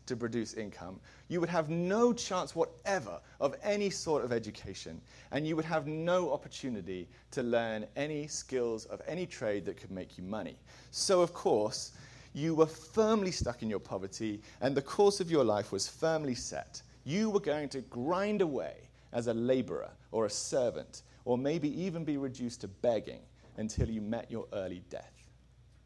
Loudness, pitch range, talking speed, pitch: -34 LUFS, 110-160 Hz, 175 wpm, 130 Hz